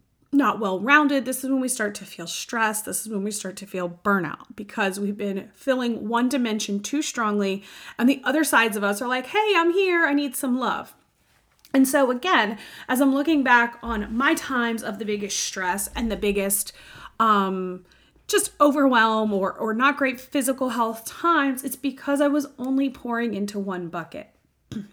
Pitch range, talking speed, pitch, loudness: 205-275 Hz, 190 wpm, 235 Hz, -23 LUFS